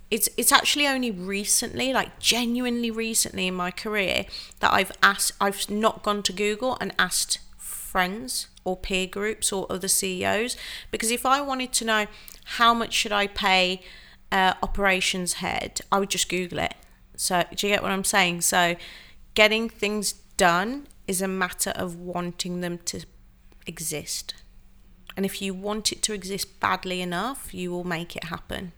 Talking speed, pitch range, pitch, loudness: 165 wpm, 180-220 Hz, 195 Hz, -24 LUFS